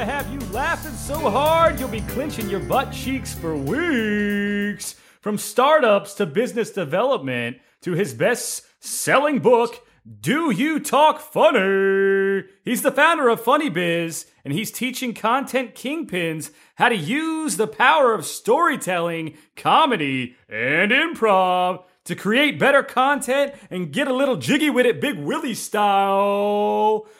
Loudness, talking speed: -20 LUFS, 135 wpm